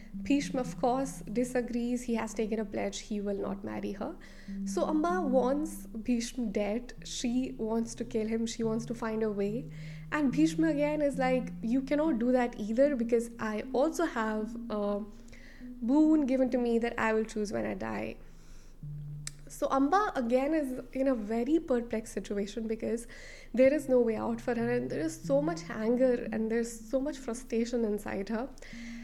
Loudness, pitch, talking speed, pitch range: -31 LUFS, 235 Hz, 180 wpm, 210-255 Hz